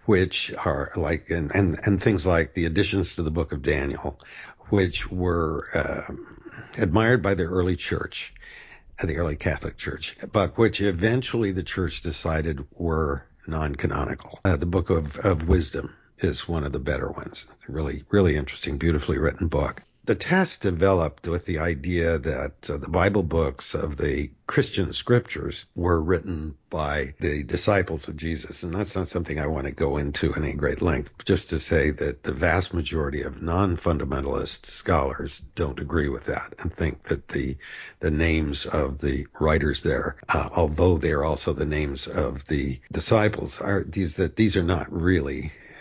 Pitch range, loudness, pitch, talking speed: 75-95 Hz, -25 LUFS, 85 Hz, 170 wpm